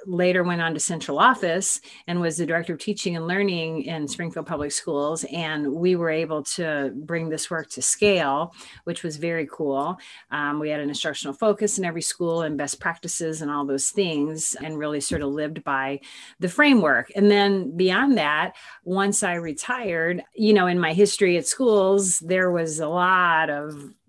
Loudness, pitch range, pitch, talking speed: -23 LUFS, 150-185 Hz, 165 Hz, 185 wpm